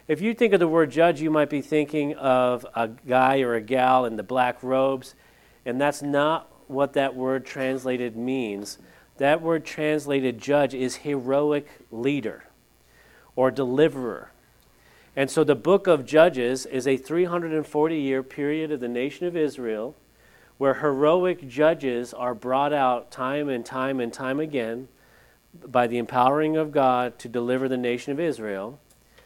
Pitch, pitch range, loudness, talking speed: 135 Hz, 125-150 Hz, -24 LUFS, 160 wpm